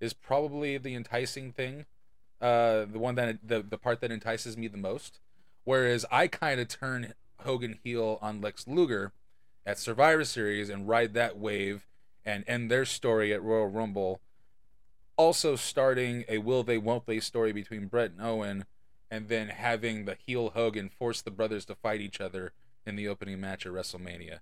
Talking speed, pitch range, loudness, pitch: 175 wpm, 105-125 Hz, -31 LUFS, 115 Hz